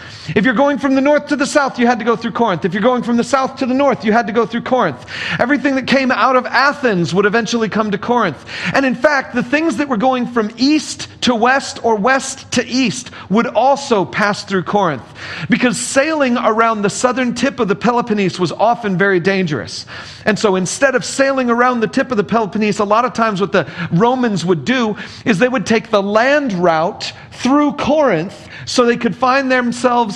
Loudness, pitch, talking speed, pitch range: -15 LUFS, 235 Hz, 215 wpm, 205-260 Hz